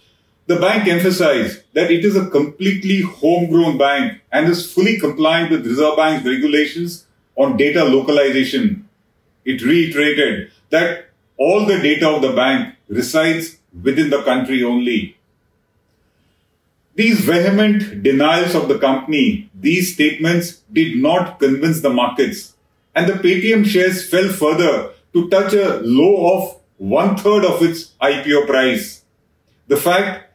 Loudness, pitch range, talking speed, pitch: -15 LUFS, 140-185 Hz, 130 wpm, 165 Hz